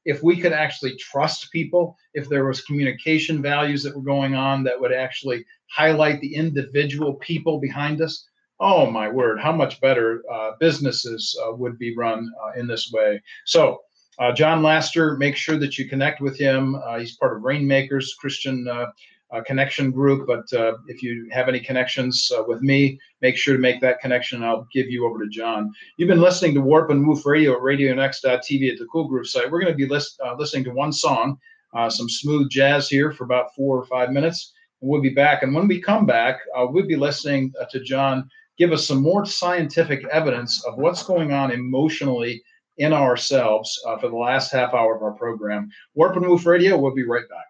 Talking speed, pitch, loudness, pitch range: 210 wpm, 135 Hz, -21 LUFS, 125-155 Hz